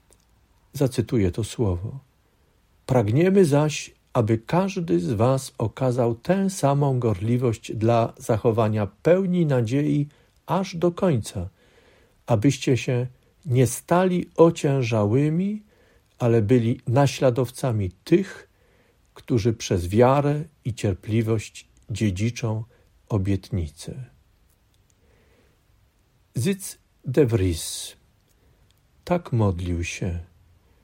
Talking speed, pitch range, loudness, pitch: 80 wpm, 105-140 Hz, -23 LUFS, 120 Hz